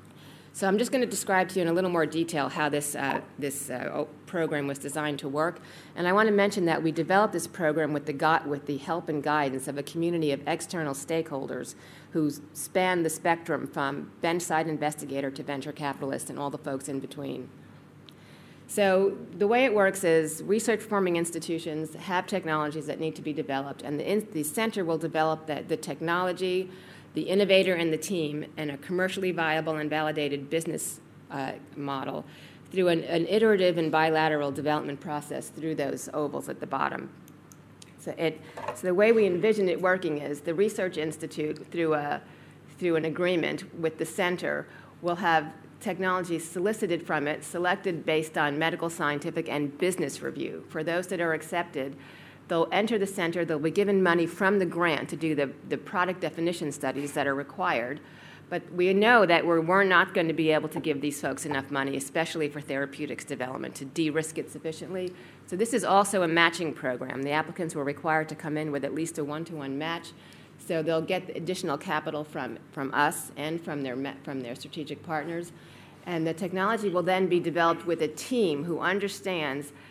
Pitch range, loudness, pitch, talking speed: 150-180 Hz, -28 LUFS, 160 Hz, 190 wpm